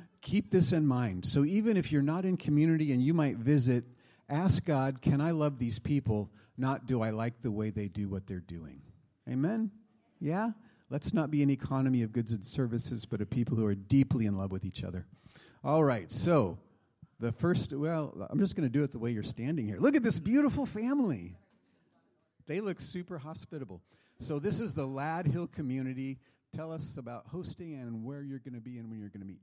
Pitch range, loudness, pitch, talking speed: 115-160 Hz, -32 LUFS, 135 Hz, 205 wpm